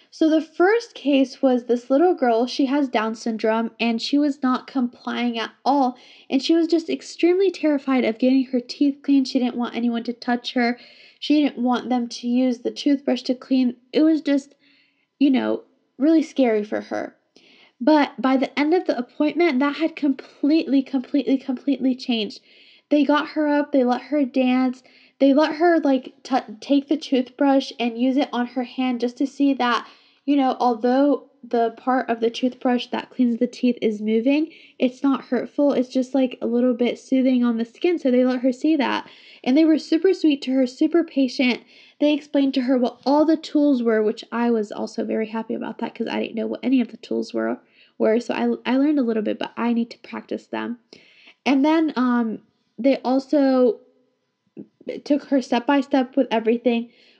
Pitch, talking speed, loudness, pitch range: 260 Hz, 200 wpm, -21 LUFS, 240-285 Hz